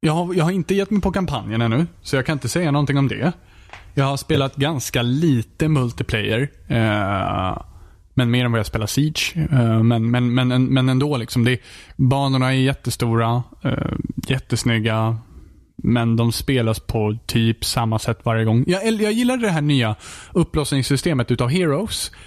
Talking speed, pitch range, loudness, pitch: 165 wpm, 115-145 Hz, -20 LUFS, 125 Hz